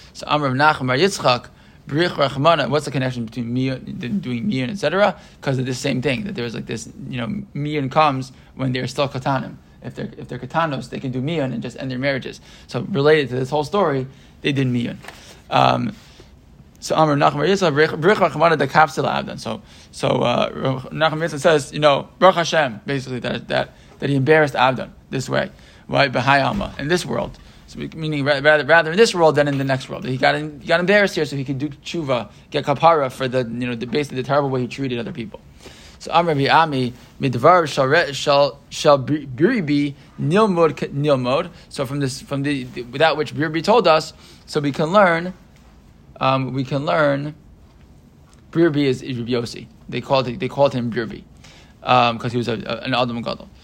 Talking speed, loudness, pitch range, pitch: 190 wpm, -19 LUFS, 130-160 Hz, 140 Hz